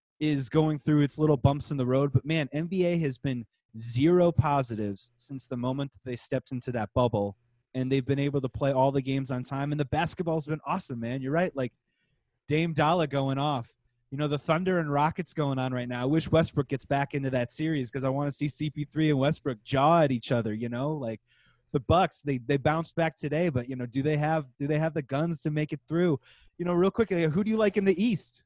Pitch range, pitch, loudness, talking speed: 130-155 Hz, 145 Hz, -28 LUFS, 245 wpm